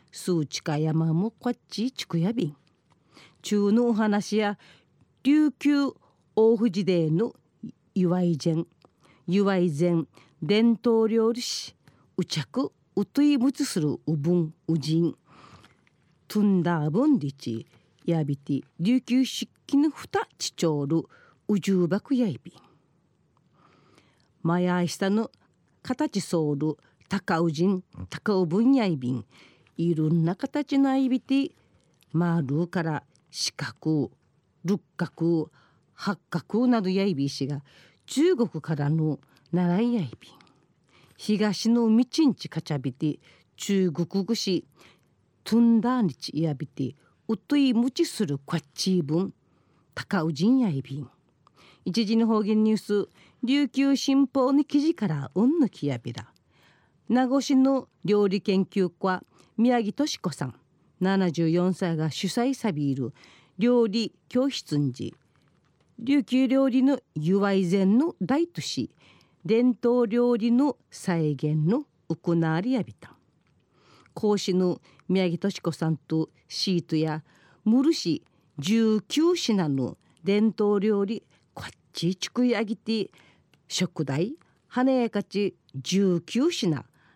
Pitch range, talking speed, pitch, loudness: 160-235 Hz, 215 characters per minute, 190 Hz, -26 LUFS